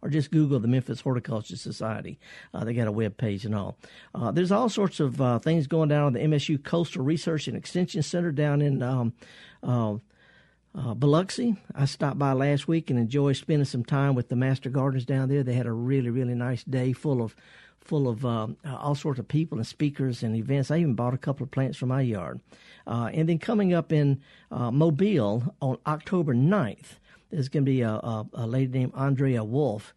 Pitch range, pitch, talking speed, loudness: 120-155 Hz, 135 Hz, 210 wpm, -27 LUFS